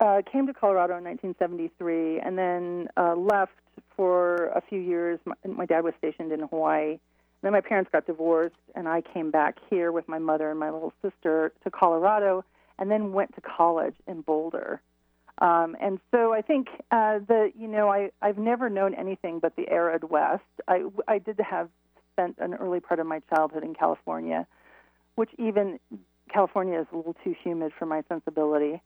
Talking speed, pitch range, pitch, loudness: 185 wpm, 160-200 Hz, 175 Hz, -27 LUFS